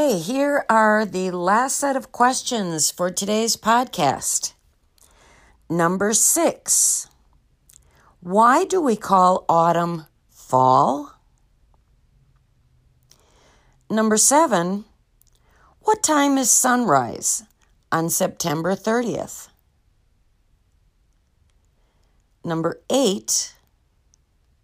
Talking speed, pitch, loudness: 70 wpm, 180 Hz, -19 LUFS